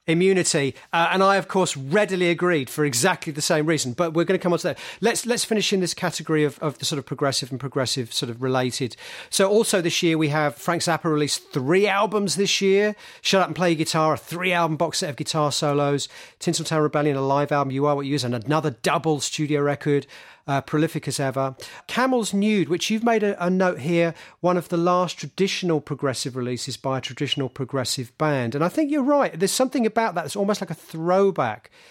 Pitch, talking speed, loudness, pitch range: 160 Hz, 225 wpm, -22 LUFS, 145-185 Hz